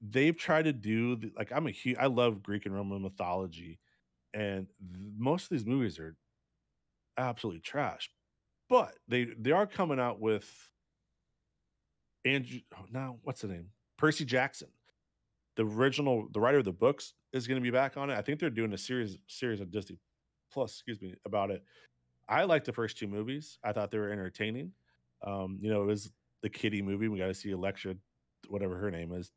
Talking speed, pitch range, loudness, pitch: 190 wpm, 95-125 Hz, -34 LUFS, 105 Hz